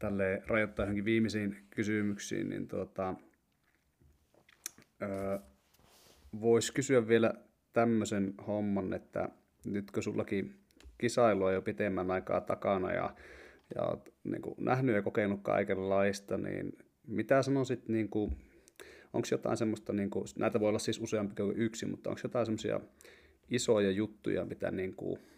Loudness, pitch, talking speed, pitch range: -34 LUFS, 105 Hz, 130 wpm, 100-115 Hz